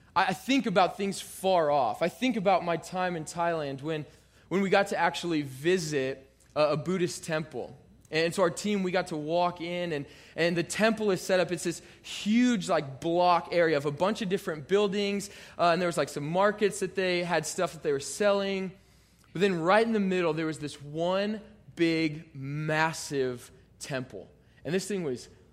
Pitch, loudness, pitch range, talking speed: 170 Hz, -28 LUFS, 155-195 Hz, 195 wpm